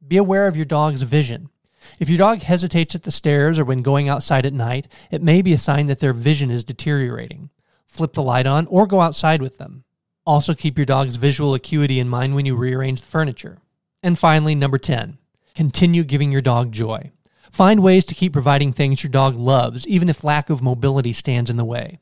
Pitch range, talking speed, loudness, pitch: 135-165 Hz, 215 wpm, -18 LUFS, 145 Hz